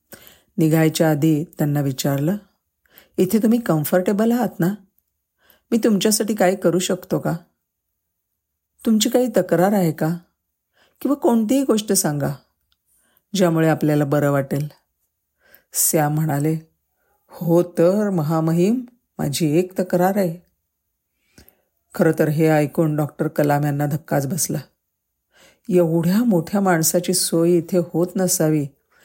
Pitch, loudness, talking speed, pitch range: 170 Hz, -19 LUFS, 110 wpm, 150-190 Hz